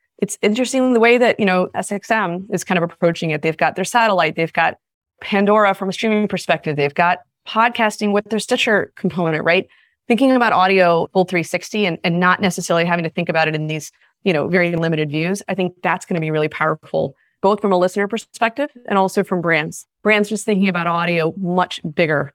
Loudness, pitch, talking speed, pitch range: -18 LUFS, 185 Hz, 205 wpm, 170-210 Hz